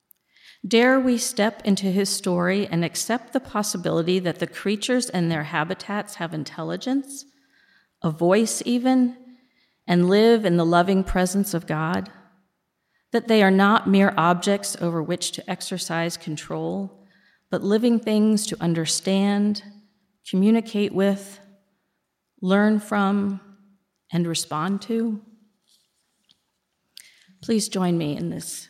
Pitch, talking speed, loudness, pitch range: 200 Hz, 120 wpm, -22 LUFS, 175-215 Hz